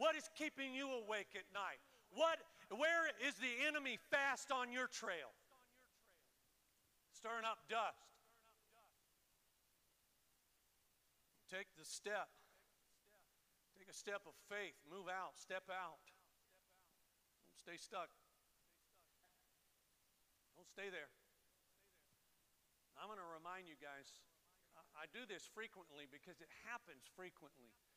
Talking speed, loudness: 110 wpm, -46 LUFS